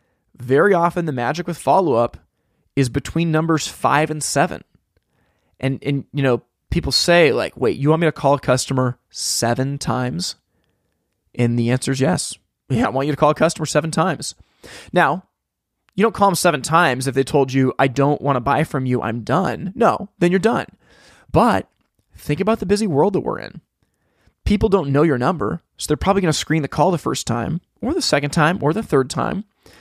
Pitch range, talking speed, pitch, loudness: 135-170 Hz, 205 wpm, 145 Hz, -19 LUFS